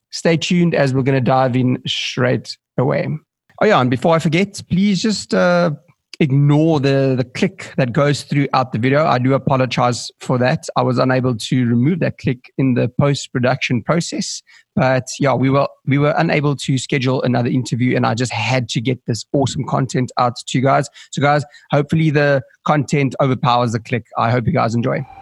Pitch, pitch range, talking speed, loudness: 135 Hz, 130-150 Hz, 195 wpm, -17 LUFS